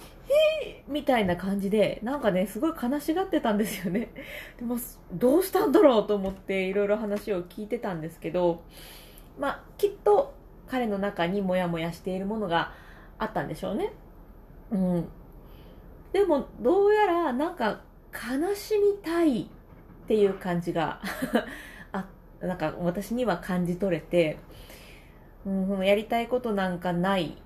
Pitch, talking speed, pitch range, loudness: 205 Hz, 295 characters per minute, 185-285 Hz, -27 LUFS